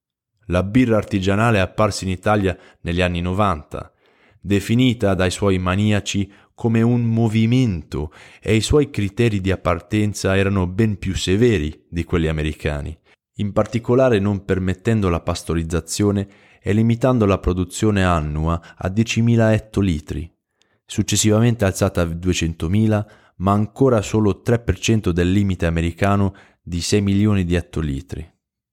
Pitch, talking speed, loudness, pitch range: 100 Hz, 125 wpm, -19 LUFS, 90-110 Hz